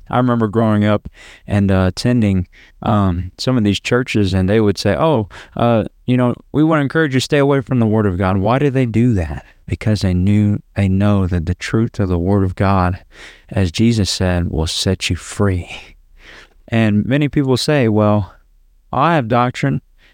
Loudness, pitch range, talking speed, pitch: -16 LUFS, 95-125 Hz, 195 wpm, 105 Hz